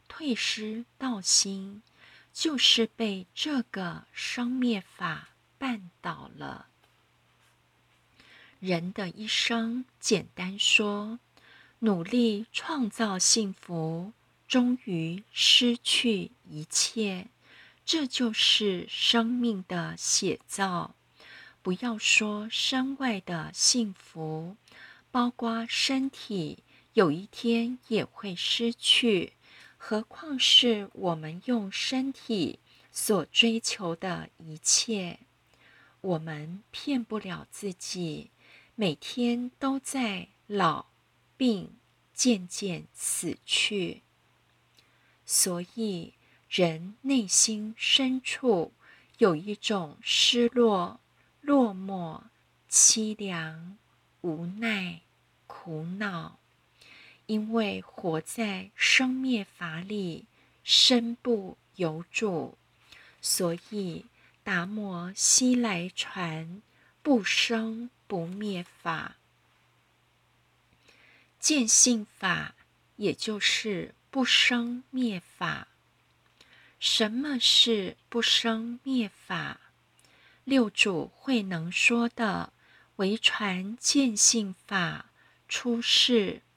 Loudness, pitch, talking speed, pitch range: -26 LUFS, 215 Hz, 115 characters per minute, 185-240 Hz